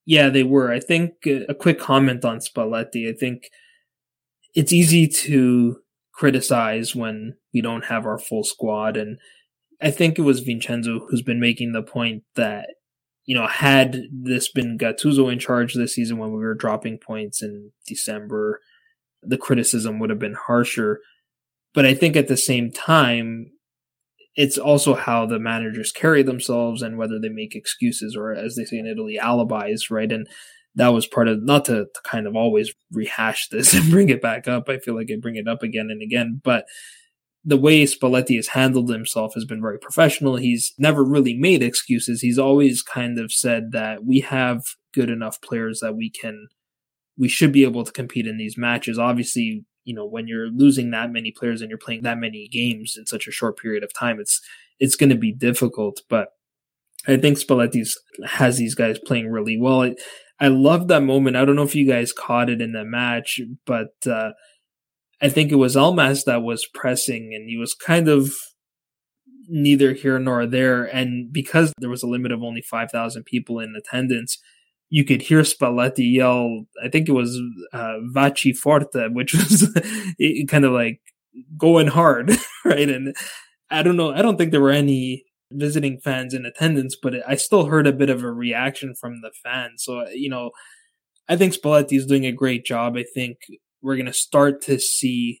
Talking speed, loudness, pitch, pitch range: 190 wpm, -20 LUFS, 125 Hz, 115-145 Hz